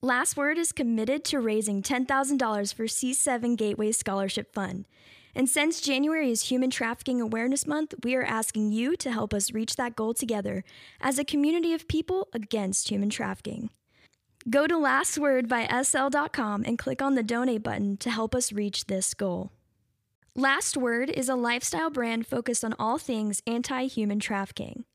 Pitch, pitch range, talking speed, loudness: 240 Hz, 215-270 Hz, 165 wpm, -27 LUFS